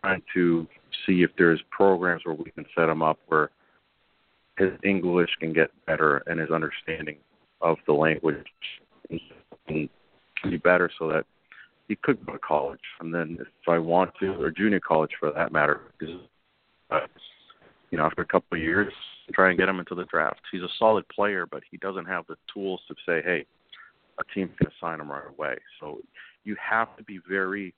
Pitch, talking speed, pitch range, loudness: 90 Hz, 190 wpm, 80-95 Hz, -26 LUFS